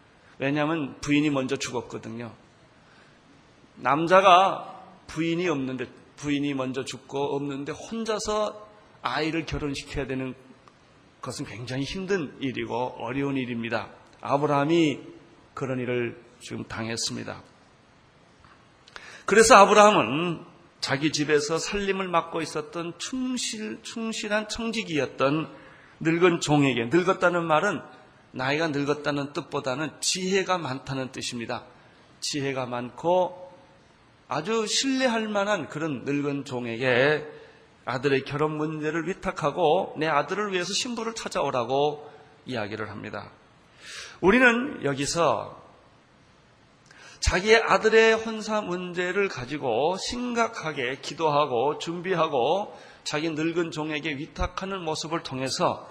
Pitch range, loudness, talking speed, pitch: 135-185 Hz, -25 LUFS, 260 characters per minute, 150 Hz